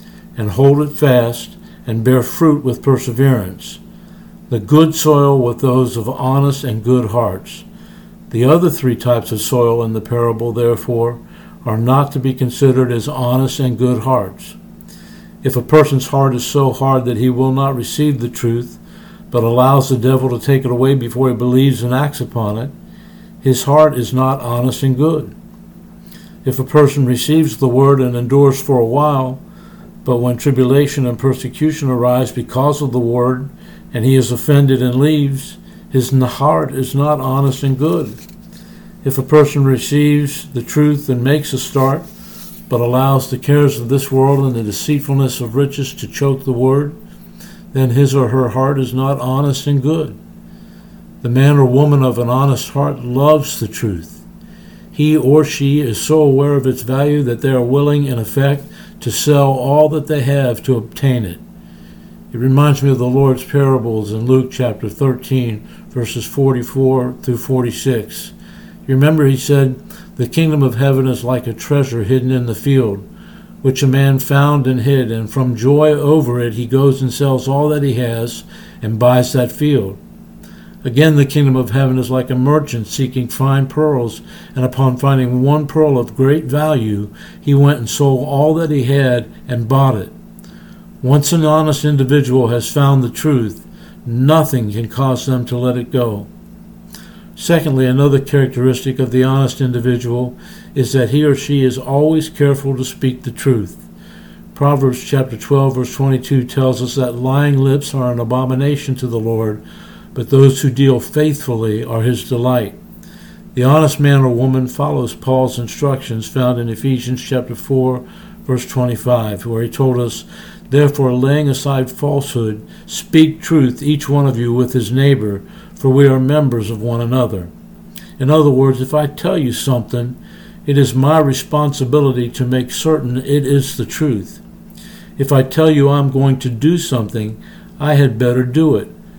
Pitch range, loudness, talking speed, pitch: 125-150 Hz, -14 LUFS, 170 wpm, 135 Hz